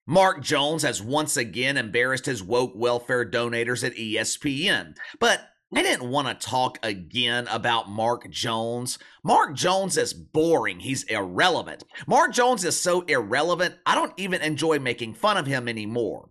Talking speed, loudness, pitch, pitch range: 155 wpm, -24 LUFS, 125 Hz, 115-155 Hz